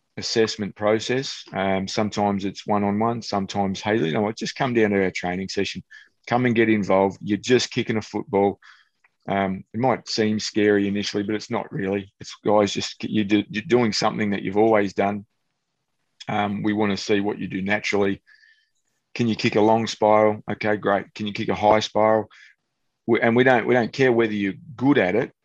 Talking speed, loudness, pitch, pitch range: 205 wpm, -22 LUFS, 105 Hz, 100-110 Hz